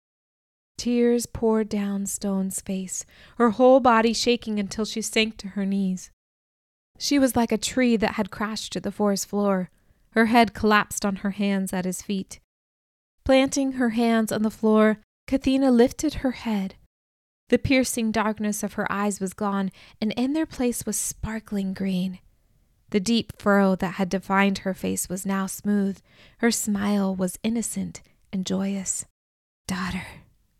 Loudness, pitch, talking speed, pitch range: -24 LUFS, 205 Hz, 155 wpm, 190-230 Hz